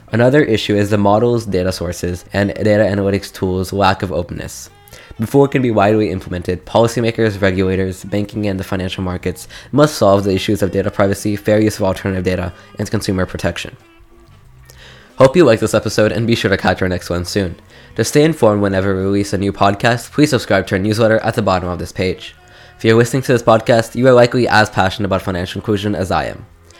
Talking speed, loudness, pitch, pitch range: 210 wpm, -15 LUFS, 100 Hz, 95-115 Hz